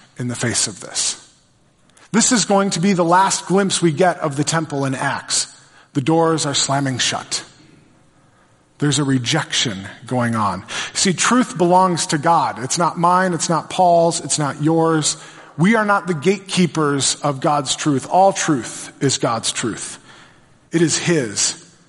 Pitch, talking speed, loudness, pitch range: 160 Hz, 165 wpm, -17 LUFS, 145-180 Hz